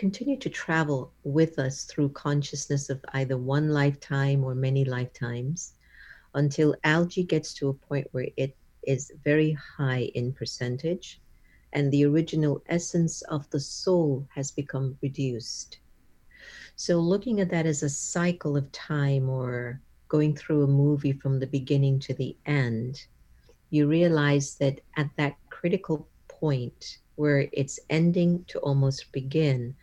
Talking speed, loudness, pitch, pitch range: 140 wpm, -27 LUFS, 145 Hz, 135-155 Hz